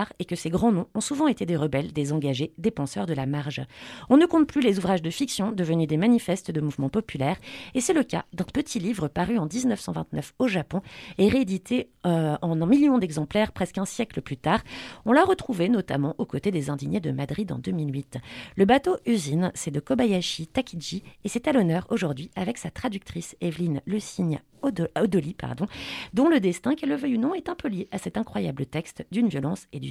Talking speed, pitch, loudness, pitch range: 215 wpm, 190 Hz, -26 LUFS, 160-235 Hz